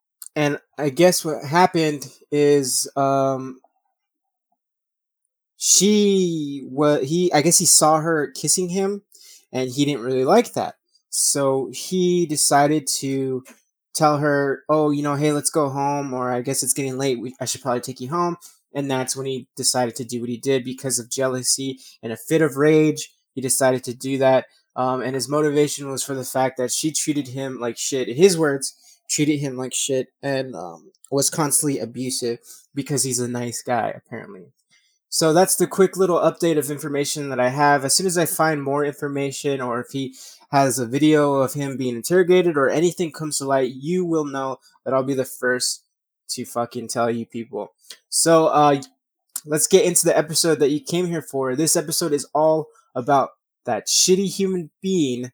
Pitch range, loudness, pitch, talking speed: 130-165 Hz, -20 LUFS, 145 Hz, 185 wpm